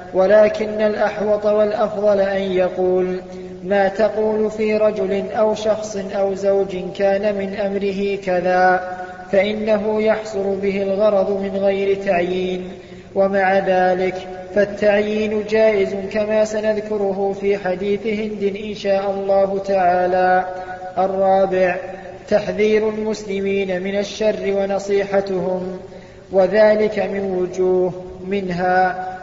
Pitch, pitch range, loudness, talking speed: 195 Hz, 185-210 Hz, -18 LUFS, 95 wpm